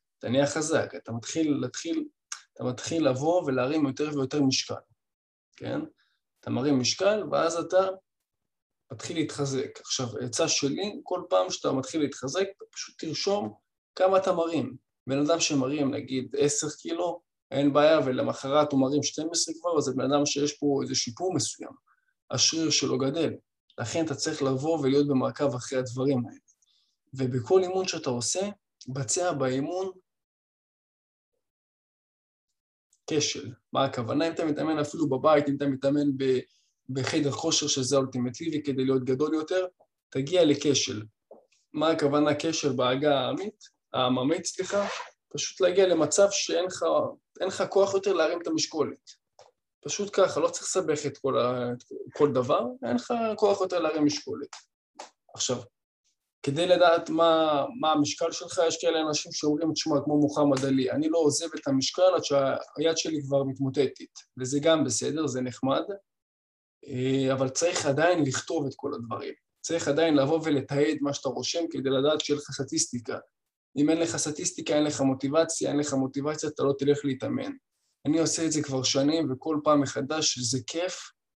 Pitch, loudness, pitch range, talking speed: 150 Hz, -27 LUFS, 135-165 Hz, 145 wpm